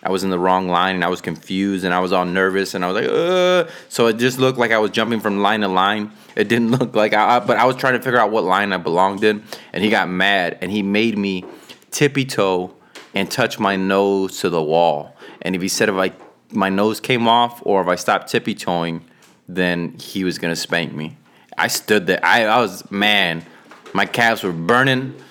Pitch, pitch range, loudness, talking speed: 100 Hz, 95-115 Hz, -18 LUFS, 235 wpm